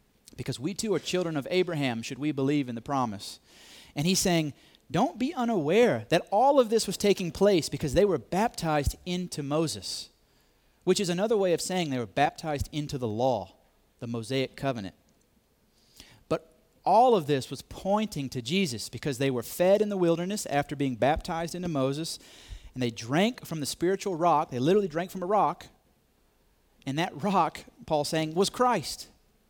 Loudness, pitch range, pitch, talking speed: -28 LUFS, 135-185 Hz, 155 Hz, 175 wpm